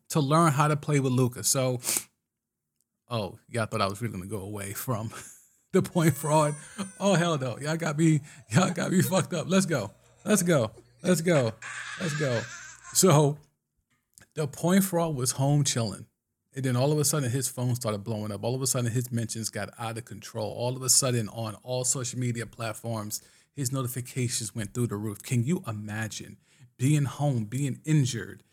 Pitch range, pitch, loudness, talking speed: 115-155 Hz, 130 Hz, -27 LUFS, 190 wpm